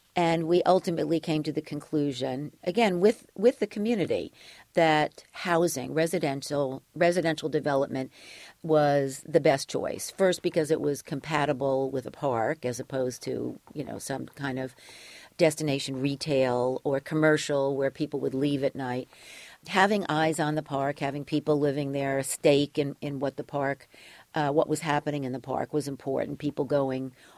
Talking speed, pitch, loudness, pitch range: 160 wpm, 145 Hz, -28 LUFS, 135-160 Hz